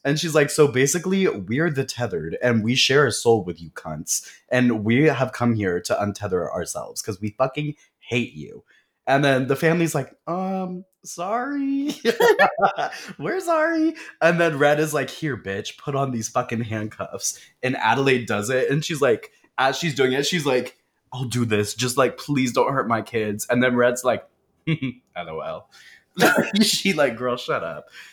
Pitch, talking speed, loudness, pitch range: 135 Hz, 180 wpm, -22 LUFS, 120-165 Hz